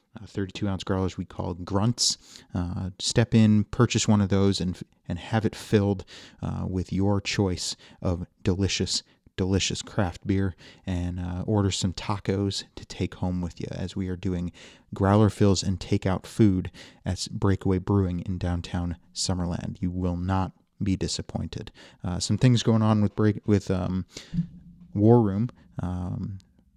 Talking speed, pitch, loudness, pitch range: 160 wpm, 95 Hz, -26 LUFS, 90-105 Hz